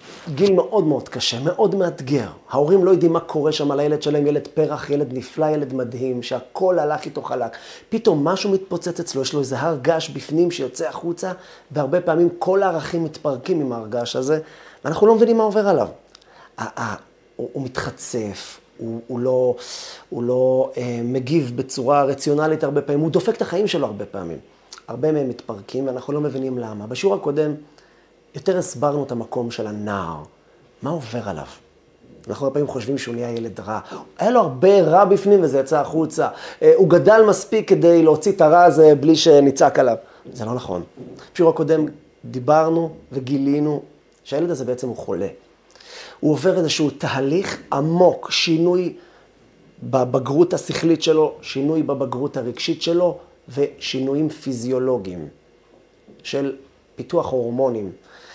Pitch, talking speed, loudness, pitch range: 145 Hz, 155 wpm, -19 LUFS, 130-170 Hz